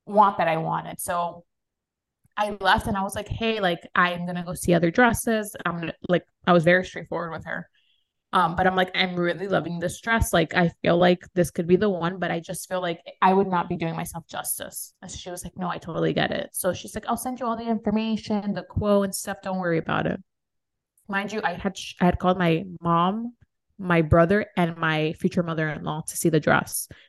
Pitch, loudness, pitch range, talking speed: 180 Hz, -24 LUFS, 170-195 Hz, 230 wpm